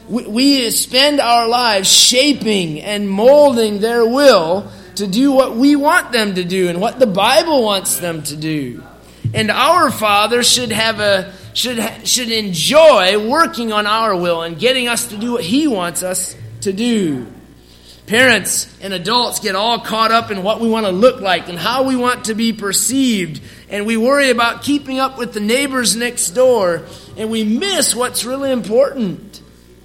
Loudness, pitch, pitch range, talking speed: -14 LUFS, 225 Hz, 195-255 Hz, 175 wpm